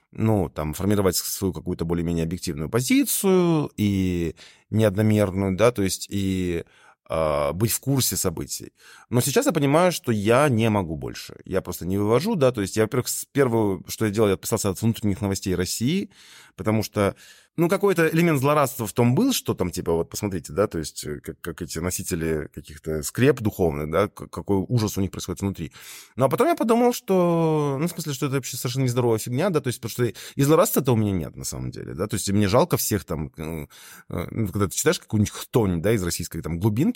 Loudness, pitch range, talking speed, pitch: -23 LUFS, 90-125 Hz, 200 wpm, 105 Hz